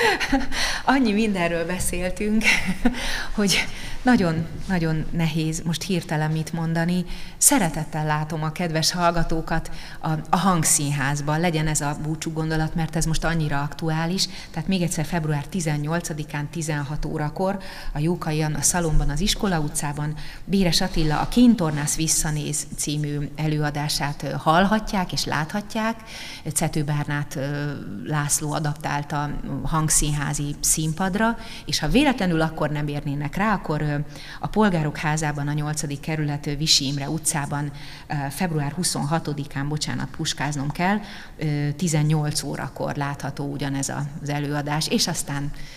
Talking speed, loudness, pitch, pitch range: 115 wpm, -23 LUFS, 155 Hz, 145-175 Hz